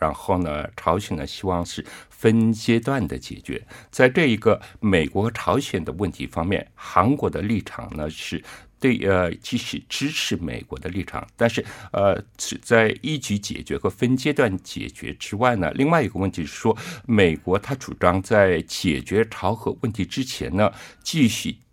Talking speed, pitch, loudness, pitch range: 245 characters per minute, 100 Hz, -23 LUFS, 90-115 Hz